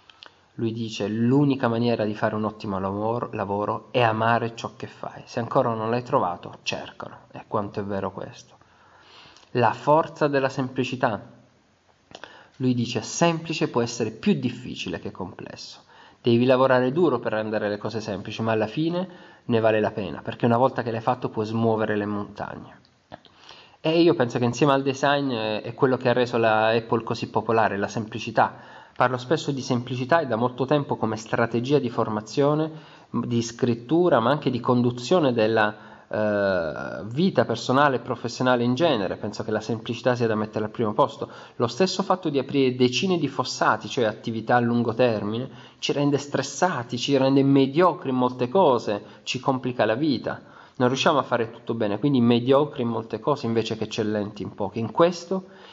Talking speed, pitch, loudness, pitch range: 175 wpm, 120 Hz, -24 LUFS, 110-135 Hz